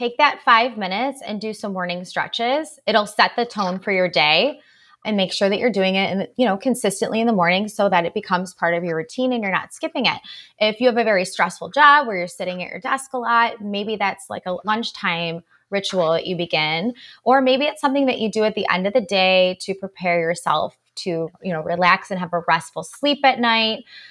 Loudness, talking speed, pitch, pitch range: -20 LUFS, 235 wpm, 200 Hz, 180-240 Hz